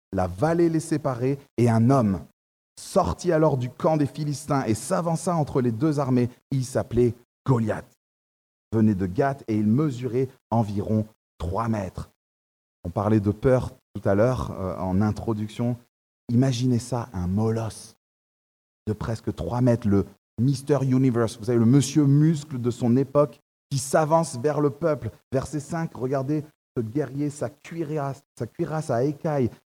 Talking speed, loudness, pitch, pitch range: 155 wpm, -24 LUFS, 125 Hz, 110-145 Hz